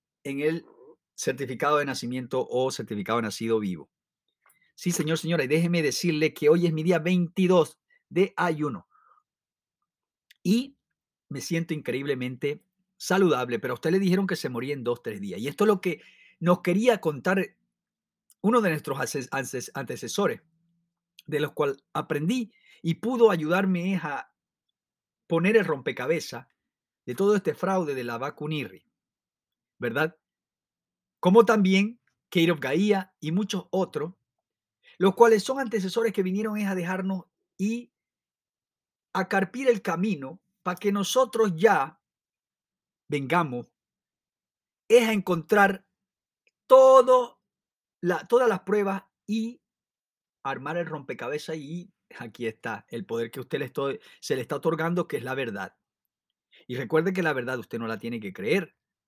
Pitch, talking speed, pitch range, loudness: 180 Hz, 140 wpm, 150-205 Hz, -26 LUFS